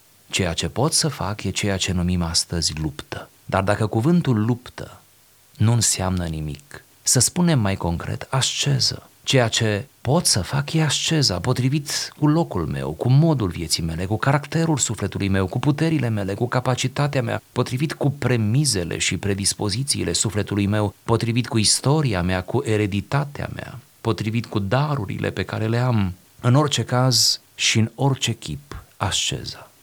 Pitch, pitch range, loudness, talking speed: 115 Hz, 95-135 Hz, -21 LUFS, 155 wpm